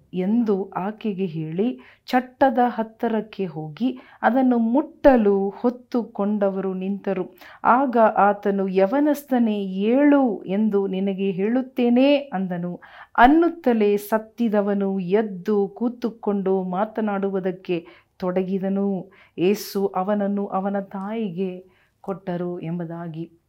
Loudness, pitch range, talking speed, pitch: -22 LUFS, 190-235 Hz, 75 wpm, 200 Hz